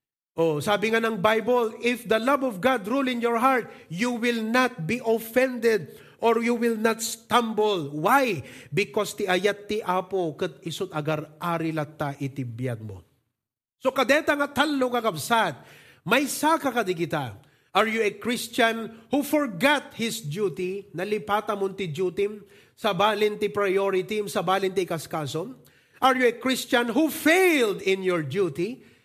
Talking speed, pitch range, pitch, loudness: 150 wpm, 170-240 Hz, 210 Hz, -25 LUFS